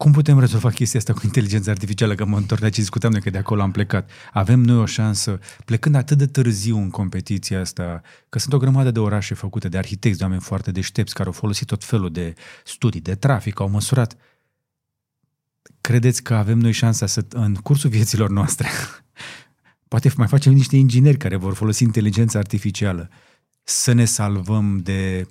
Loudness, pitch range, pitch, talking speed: -19 LUFS, 100-125 Hz, 110 Hz, 185 wpm